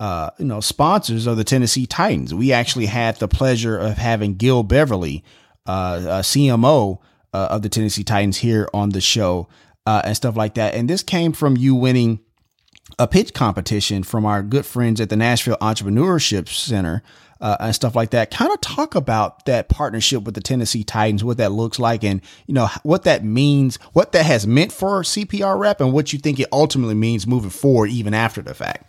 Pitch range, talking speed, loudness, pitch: 105-130 Hz, 200 wpm, -18 LUFS, 115 Hz